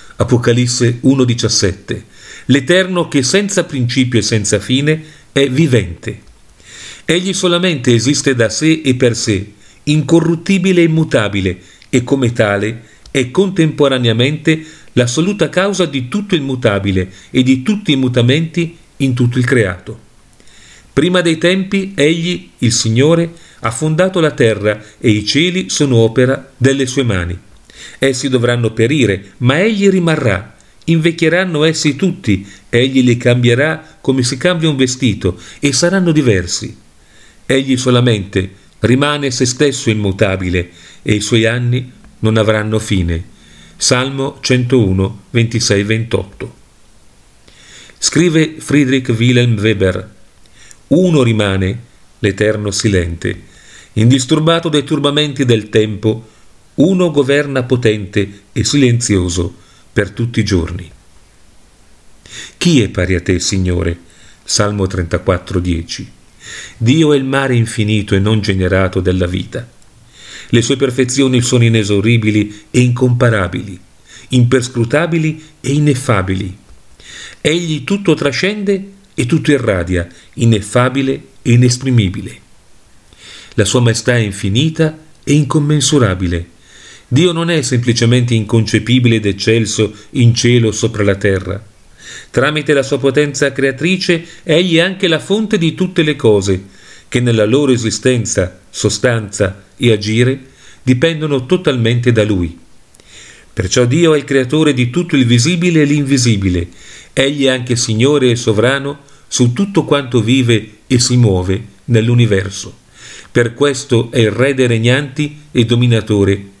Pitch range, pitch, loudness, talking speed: 105-145 Hz, 120 Hz, -13 LUFS, 120 wpm